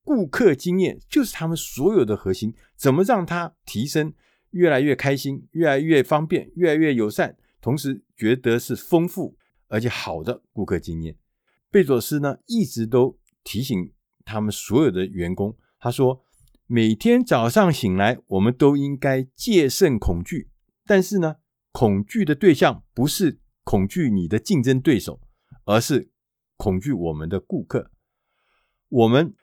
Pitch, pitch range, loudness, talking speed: 130 Hz, 105-165 Hz, -21 LUFS, 225 characters per minute